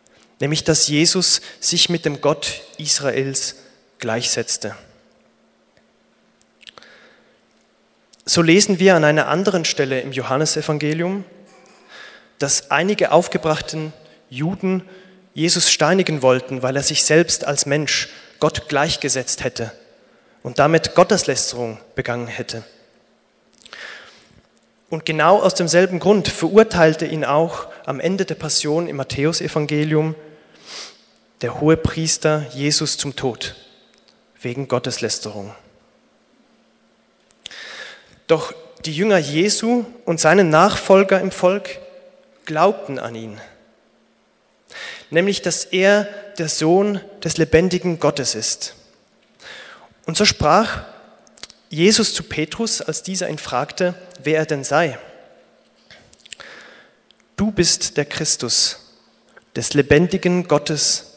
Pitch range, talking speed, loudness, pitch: 145-180 Hz, 100 wpm, -16 LUFS, 155 Hz